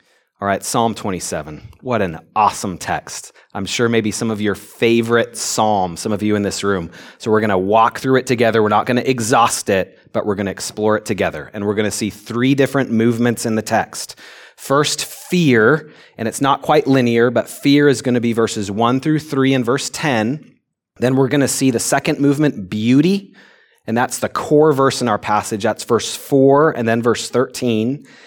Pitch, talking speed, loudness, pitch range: 115 Hz, 210 wpm, -17 LUFS, 110-135 Hz